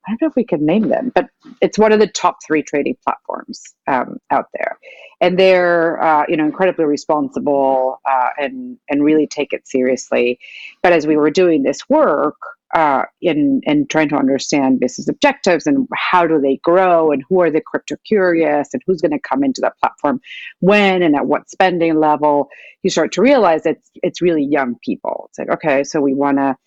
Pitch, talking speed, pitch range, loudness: 165 Hz, 205 wpm, 145-190 Hz, -16 LUFS